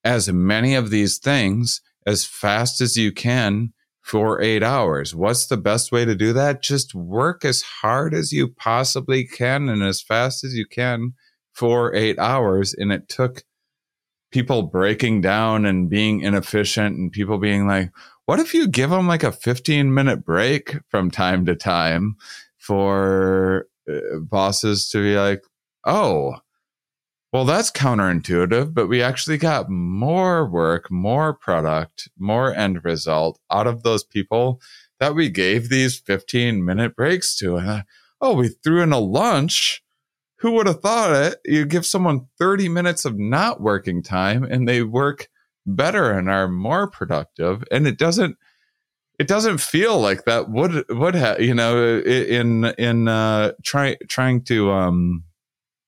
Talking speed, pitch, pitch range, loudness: 155 wpm, 115 Hz, 100-135 Hz, -19 LUFS